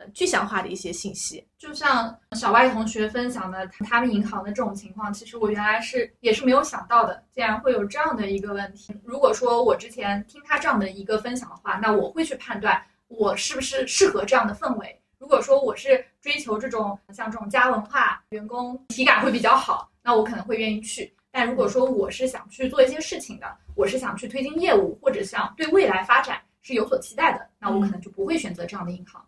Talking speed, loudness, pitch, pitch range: 340 characters per minute, -23 LUFS, 235 Hz, 210-270 Hz